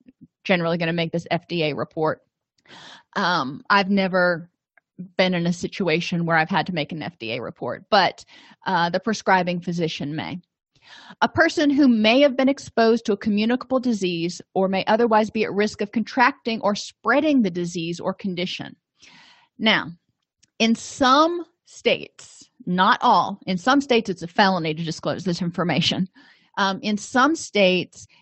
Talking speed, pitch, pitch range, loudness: 155 wpm, 195 Hz, 175-235 Hz, -21 LUFS